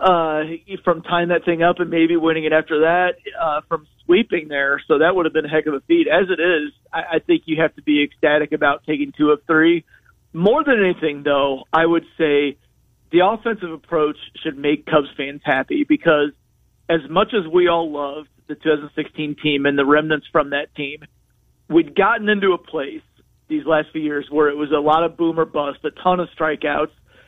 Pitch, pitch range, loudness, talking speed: 155 Hz, 150-175 Hz, -19 LUFS, 210 wpm